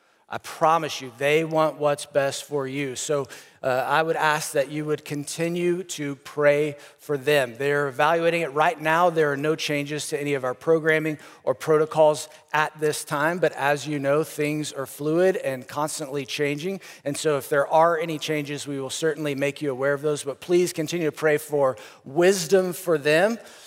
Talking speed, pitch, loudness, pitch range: 190 wpm, 150 Hz, -24 LUFS, 145-160 Hz